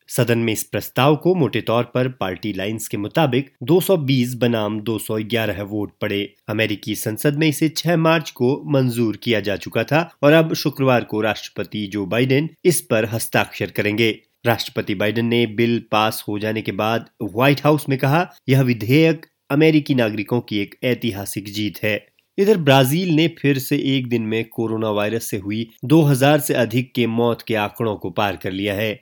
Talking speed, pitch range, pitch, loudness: 180 wpm, 110-140 Hz, 120 Hz, -19 LUFS